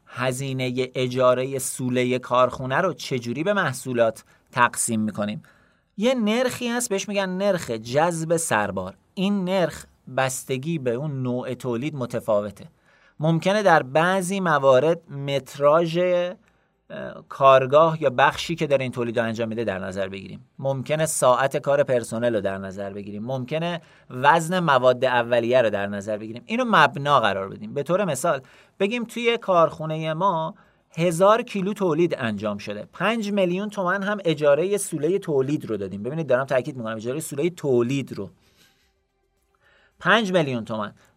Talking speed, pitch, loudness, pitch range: 145 wpm, 140 Hz, -23 LUFS, 120-180 Hz